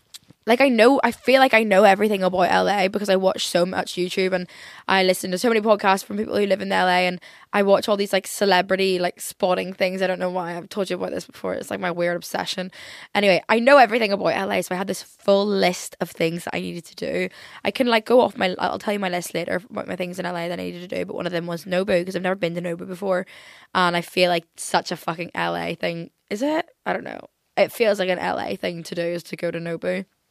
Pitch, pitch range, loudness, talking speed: 185 Hz, 175-200 Hz, -21 LUFS, 270 wpm